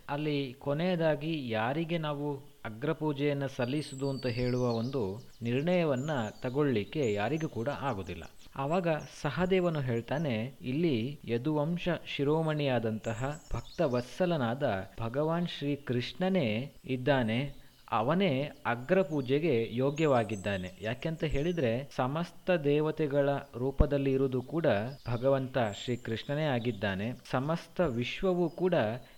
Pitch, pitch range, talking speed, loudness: 140 Hz, 120-155 Hz, 95 wpm, -32 LUFS